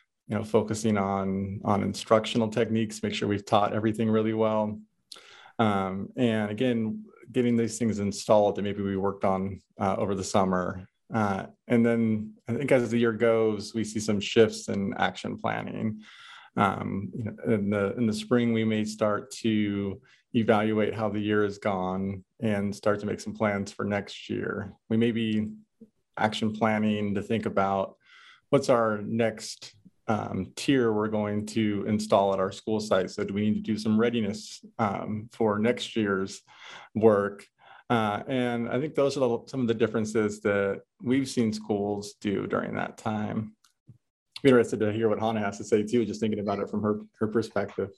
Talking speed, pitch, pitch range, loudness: 180 wpm, 110 Hz, 100-115 Hz, -27 LUFS